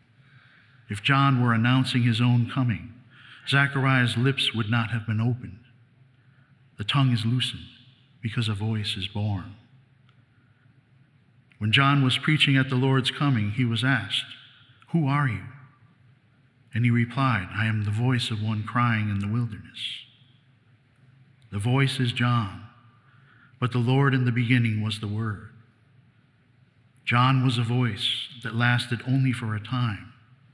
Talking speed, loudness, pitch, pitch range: 145 wpm, -24 LUFS, 125 Hz, 115-130 Hz